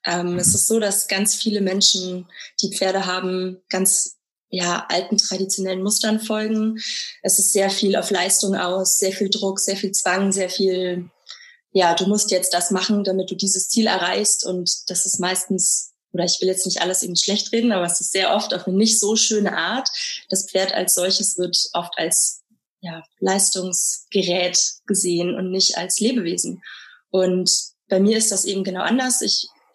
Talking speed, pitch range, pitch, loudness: 180 wpm, 180-205 Hz, 190 Hz, -19 LUFS